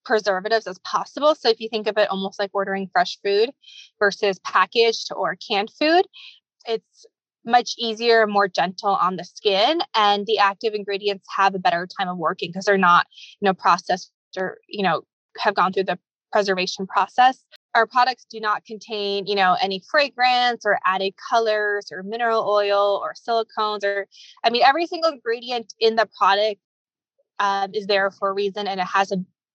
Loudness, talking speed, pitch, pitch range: -21 LUFS, 180 wpm, 210 Hz, 195-235 Hz